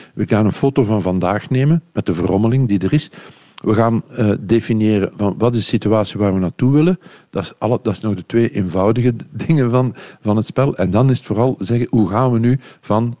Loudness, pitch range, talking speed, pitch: -17 LUFS, 105-125 Hz, 220 wpm, 115 Hz